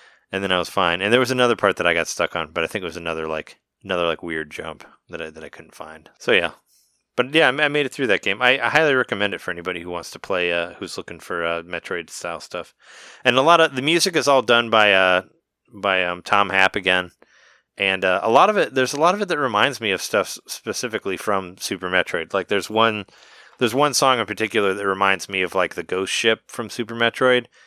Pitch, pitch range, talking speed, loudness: 105 Hz, 90-125 Hz, 255 wpm, -20 LUFS